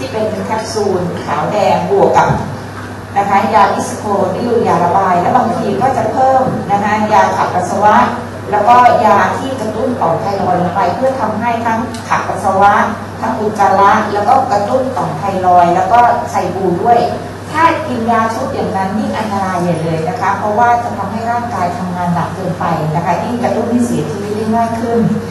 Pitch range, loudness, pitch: 185-235 Hz, -13 LUFS, 205 Hz